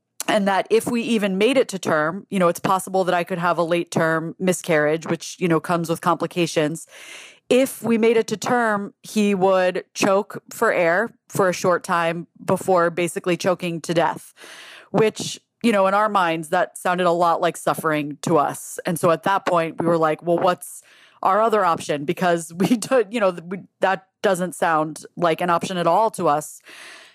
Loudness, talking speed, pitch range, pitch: -21 LUFS, 195 wpm, 170-200 Hz, 180 Hz